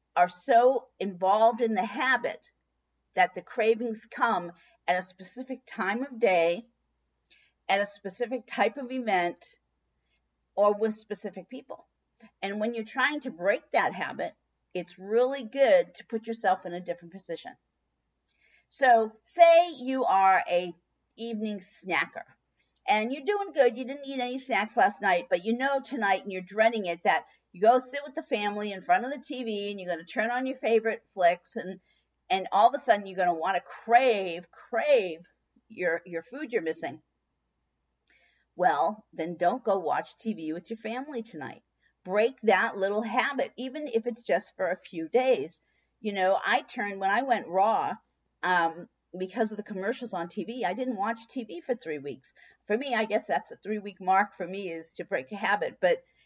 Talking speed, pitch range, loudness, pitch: 180 wpm, 185-250 Hz, -28 LUFS, 220 Hz